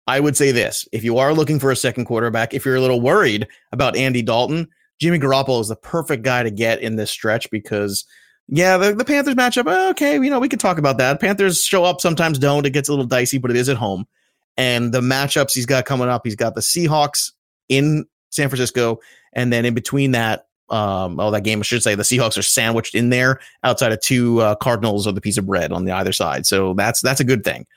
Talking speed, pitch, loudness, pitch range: 240 wpm, 130 Hz, -18 LUFS, 115-145 Hz